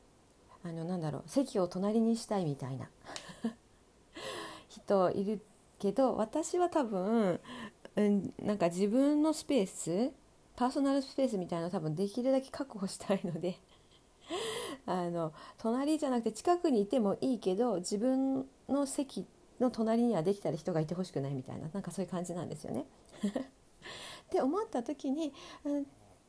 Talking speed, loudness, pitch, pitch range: 305 characters per minute, -34 LUFS, 220 Hz, 185-270 Hz